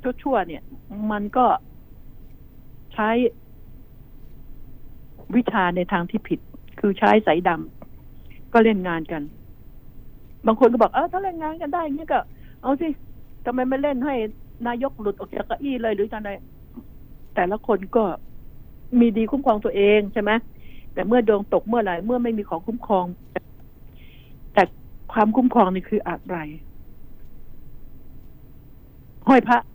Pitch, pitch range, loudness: 220 Hz, 200-245 Hz, -22 LUFS